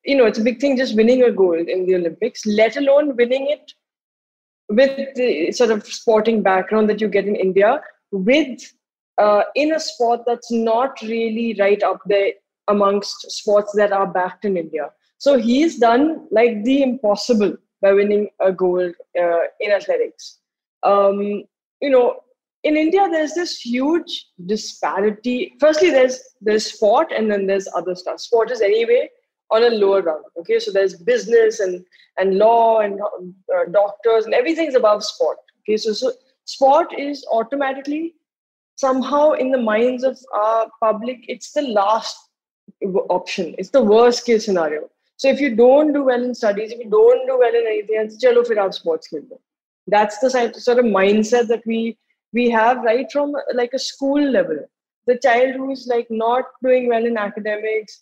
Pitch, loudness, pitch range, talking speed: 230 Hz, -18 LUFS, 205-265 Hz, 170 wpm